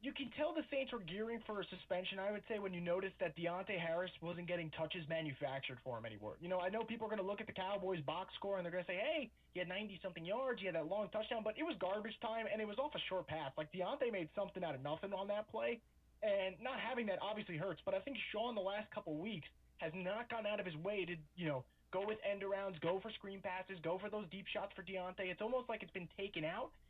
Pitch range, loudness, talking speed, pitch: 175-215 Hz, -43 LUFS, 275 wpm, 195 Hz